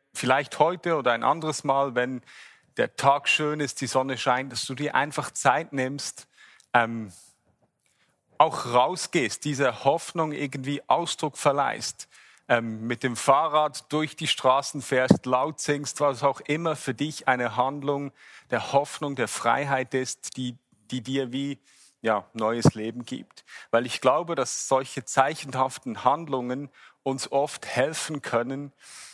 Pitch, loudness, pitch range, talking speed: 135 Hz, -26 LUFS, 125-145 Hz, 140 wpm